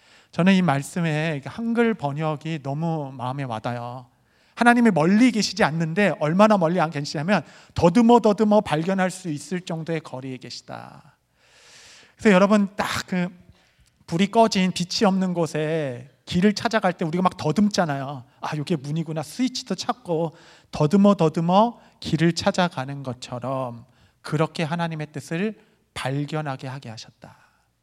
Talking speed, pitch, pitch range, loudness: 305 characters per minute, 165 Hz, 140-200 Hz, -22 LUFS